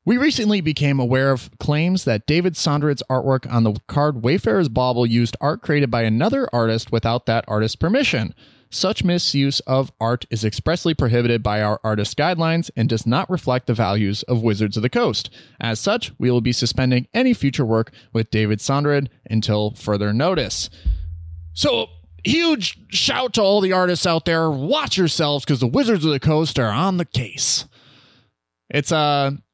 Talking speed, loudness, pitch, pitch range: 175 wpm, -20 LUFS, 130 Hz, 115-160 Hz